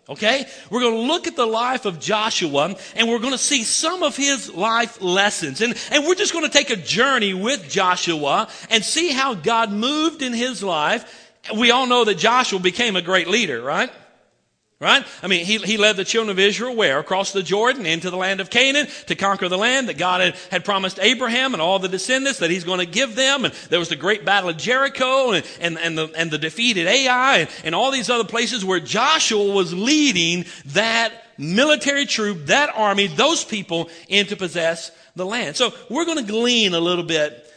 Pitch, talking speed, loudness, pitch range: 220 Hz, 210 wpm, -18 LUFS, 185-255 Hz